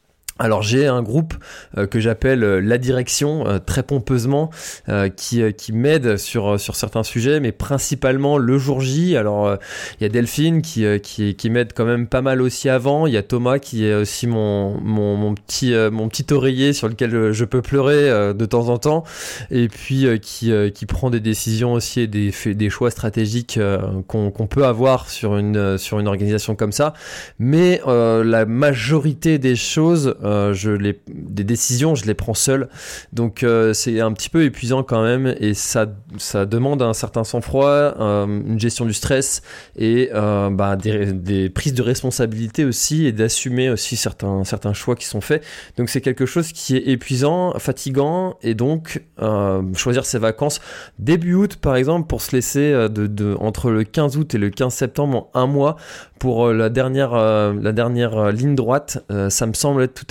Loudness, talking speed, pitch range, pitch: -18 LUFS, 195 wpm, 105-135 Hz, 120 Hz